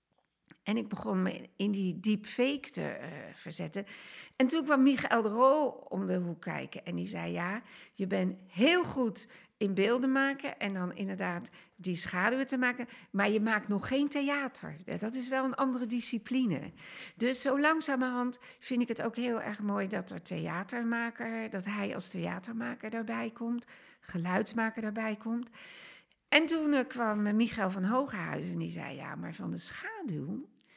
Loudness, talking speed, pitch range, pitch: -33 LUFS, 170 wpm, 195-255 Hz, 225 Hz